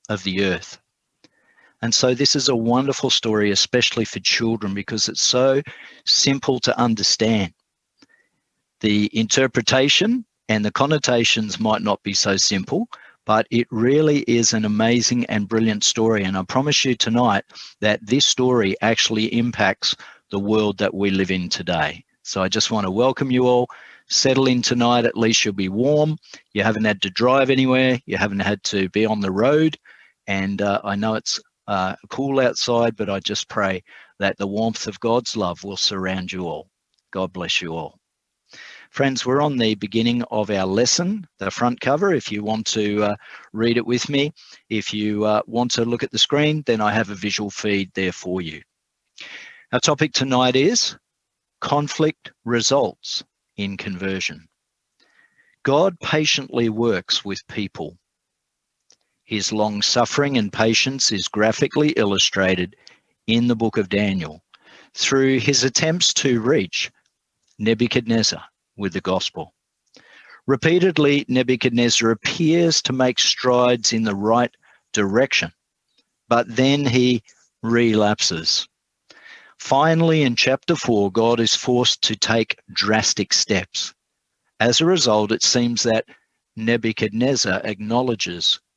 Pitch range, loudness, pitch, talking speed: 105-130 Hz, -19 LUFS, 115 Hz, 145 wpm